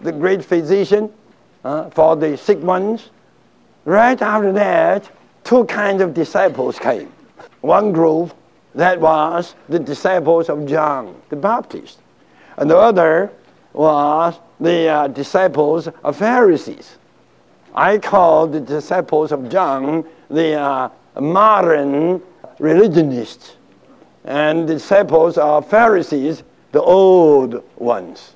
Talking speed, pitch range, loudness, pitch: 110 wpm, 150-190 Hz, -15 LUFS, 165 Hz